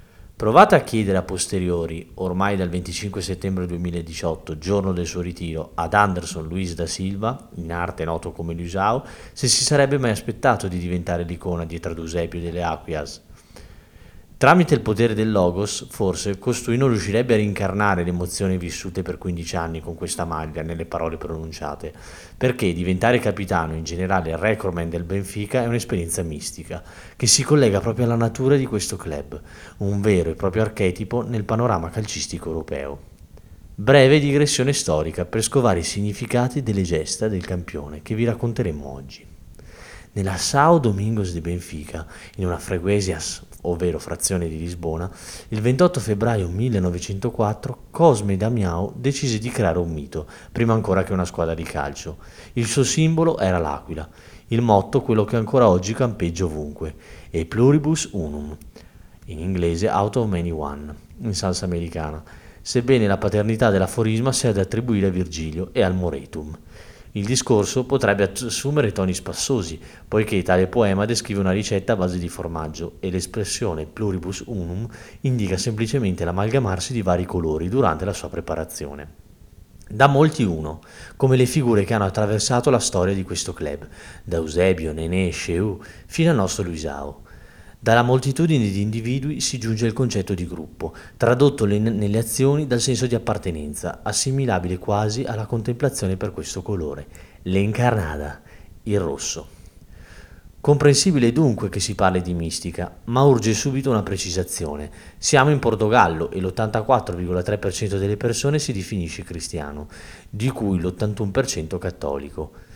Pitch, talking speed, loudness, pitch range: 95 Hz, 145 wpm, -22 LUFS, 85-115 Hz